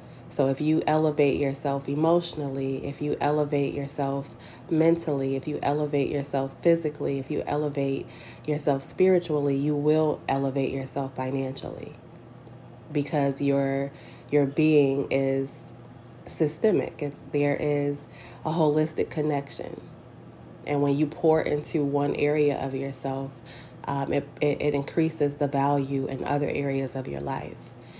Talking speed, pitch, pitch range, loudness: 130 wpm, 140 Hz, 135-150 Hz, -26 LUFS